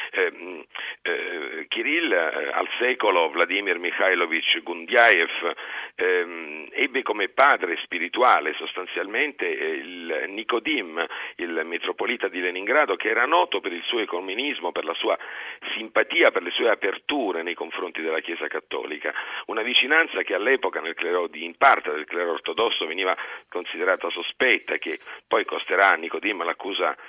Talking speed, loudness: 140 wpm, -23 LUFS